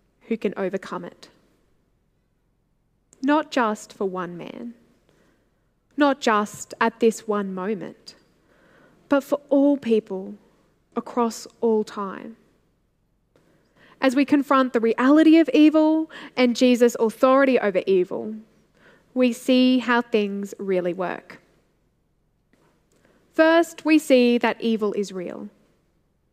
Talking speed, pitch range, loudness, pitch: 105 wpm, 210-265 Hz, -21 LUFS, 235 Hz